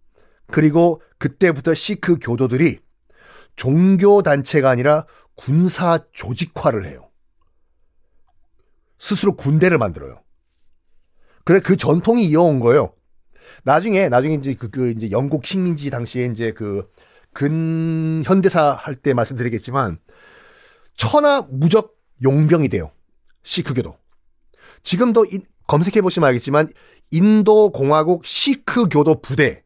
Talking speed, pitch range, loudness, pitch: 250 characters per minute, 130-190 Hz, -17 LUFS, 155 Hz